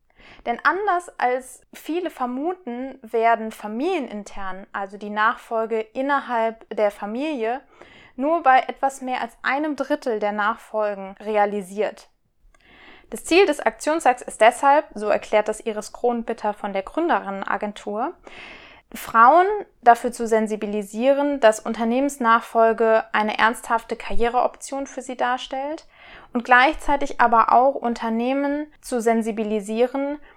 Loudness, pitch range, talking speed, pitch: -21 LUFS, 220-275 Hz, 110 wpm, 235 Hz